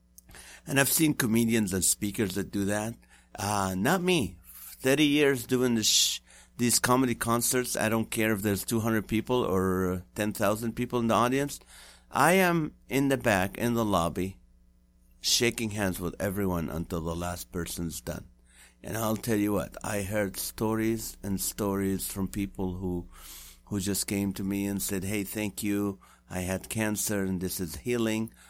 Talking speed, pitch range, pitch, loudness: 170 wpm, 90-115 Hz, 100 Hz, -28 LUFS